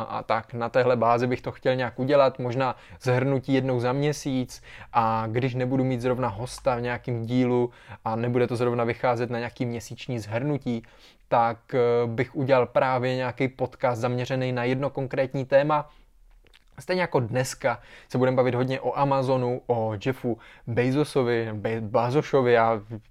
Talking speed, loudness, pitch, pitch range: 150 wpm, -25 LUFS, 125 Hz, 120-130 Hz